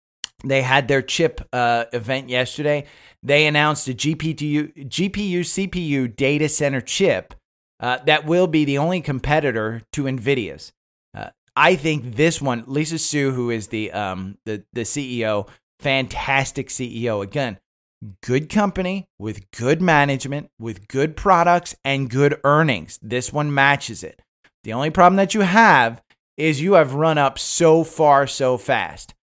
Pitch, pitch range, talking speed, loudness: 140 Hz, 120-155 Hz, 150 wpm, -19 LUFS